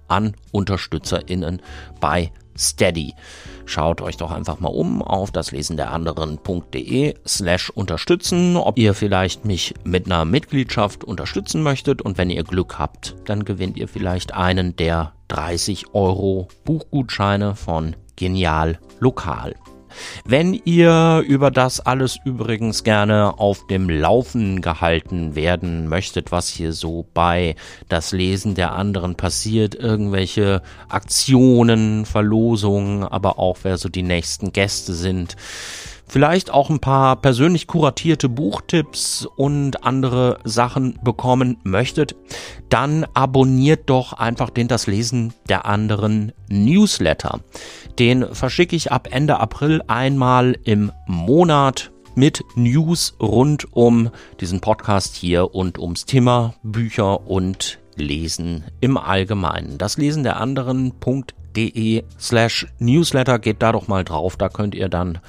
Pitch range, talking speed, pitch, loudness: 90-125 Hz, 125 wpm, 105 Hz, -19 LUFS